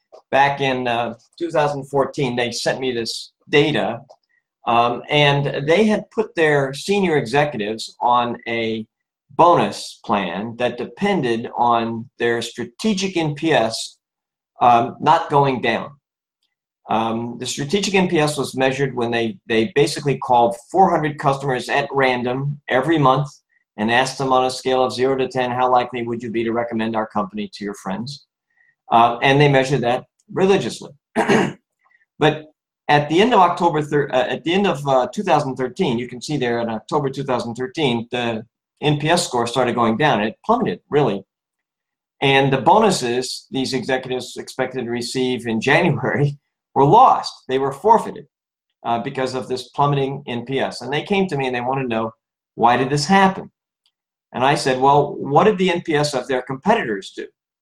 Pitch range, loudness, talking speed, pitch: 120-150 Hz, -19 LUFS, 160 wpm, 135 Hz